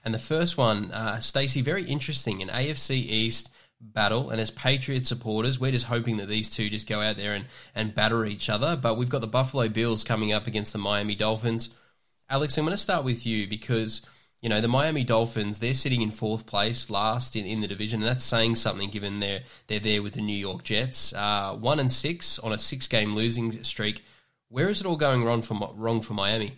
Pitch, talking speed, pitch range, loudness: 115 Hz, 225 wpm, 105-130 Hz, -26 LUFS